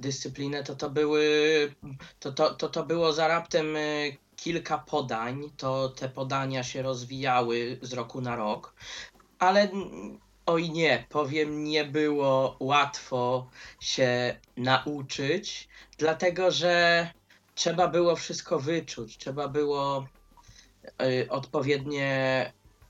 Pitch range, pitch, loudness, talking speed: 130-155 Hz, 145 Hz, -28 LUFS, 105 wpm